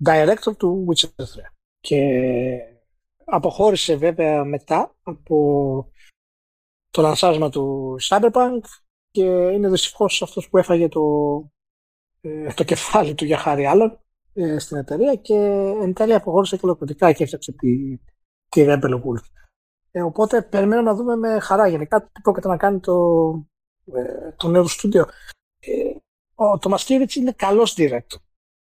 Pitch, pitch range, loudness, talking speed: 170 Hz, 145-200 Hz, -19 LUFS, 130 wpm